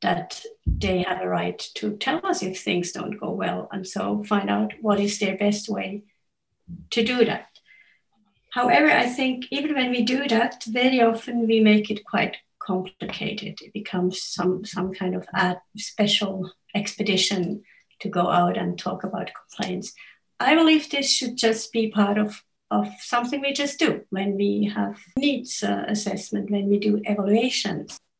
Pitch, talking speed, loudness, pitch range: 210 Hz, 170 wpm, -24 LUFS, 190-235 Hz